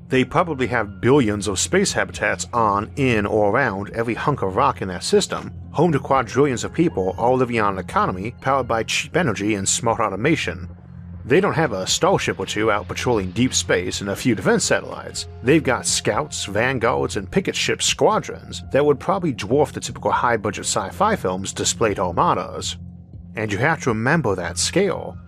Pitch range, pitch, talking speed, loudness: 90-135 Hz, 110 Hz, 185 wpm, -20 LUFS